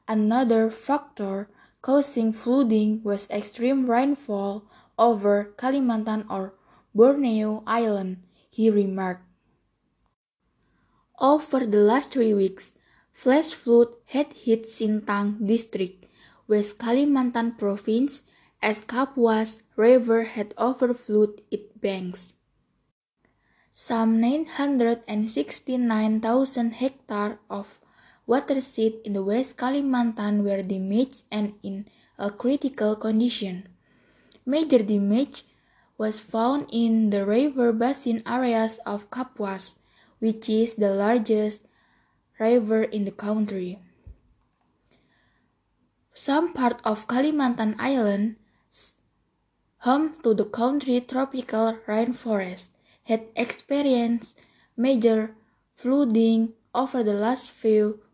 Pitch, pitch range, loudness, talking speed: 225 Hz, 210-250 Hz, -24 LUFS, 95 wpm